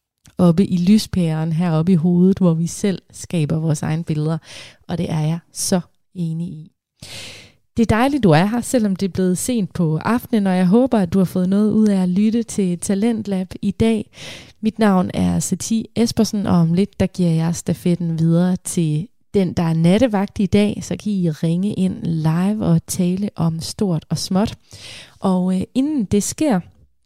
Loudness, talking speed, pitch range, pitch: -18 LUFS, 190 wpm, 165-205 Hz, 185 Hz